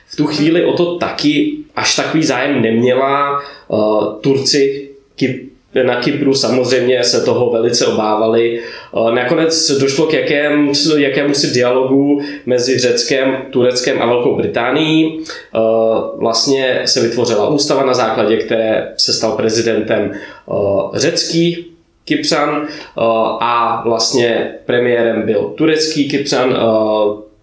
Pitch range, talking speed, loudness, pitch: 115-150 Hz, 105 wpm, -14 LUFS, 130 Hz